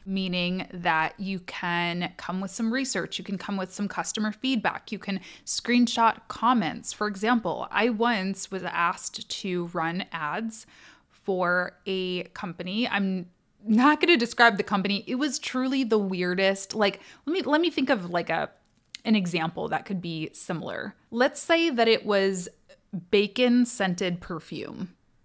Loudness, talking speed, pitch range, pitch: -26 LUFS, 155 wpm, 180-235 Hz, 200 Hz